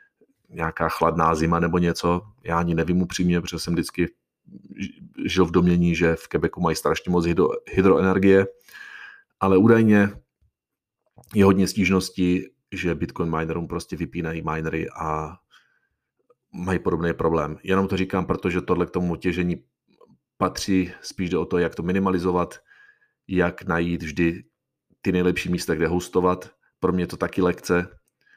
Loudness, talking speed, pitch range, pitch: -23 LUFS, 140 wpm, 85-95 Hz, 90 Hz